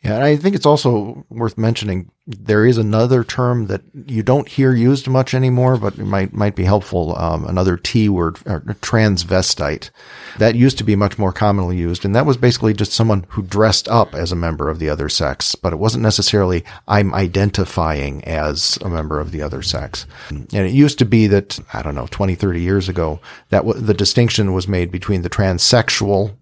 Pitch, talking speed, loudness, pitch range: 100 Hz, 205 wpm, -16 LUFS, 90-115 Hz